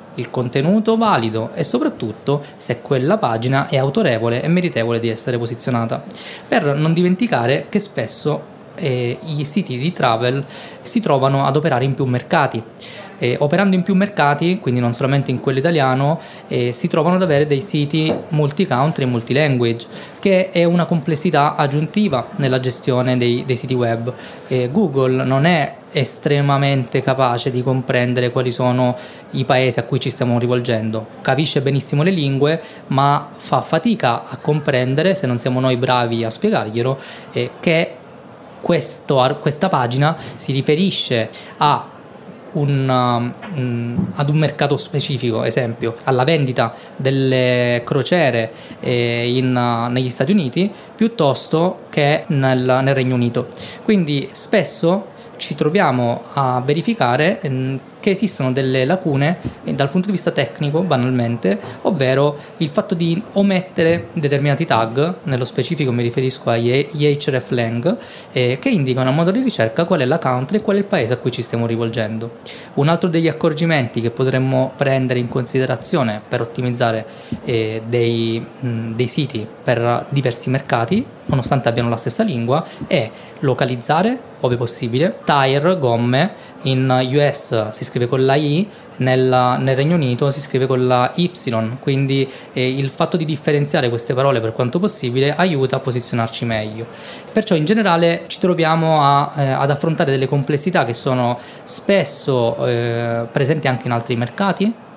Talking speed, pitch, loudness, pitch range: 150 wpm, 135 Hz, -18 LUFS, 125-160 Hz